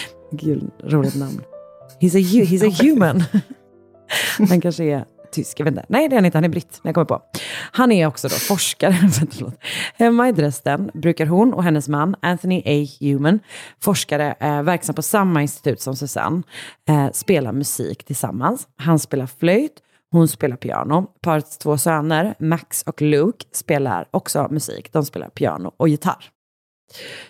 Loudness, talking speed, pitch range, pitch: -19 LUFS, 155 wpm, 145-185 Hz, 160 Hz